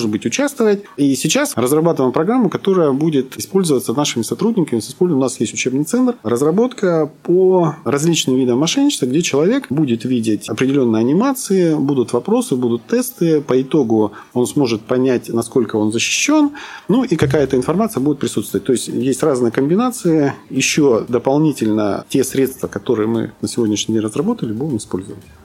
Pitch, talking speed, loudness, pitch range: 135 Hz, 145 wpm, -16 LUFS, 115-175 Hz